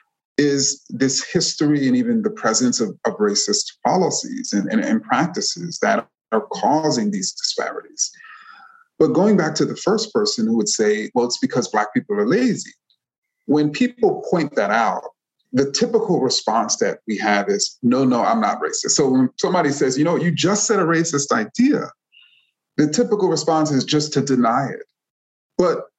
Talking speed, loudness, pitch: 175 wpm, -19 LUFS, 205 Hz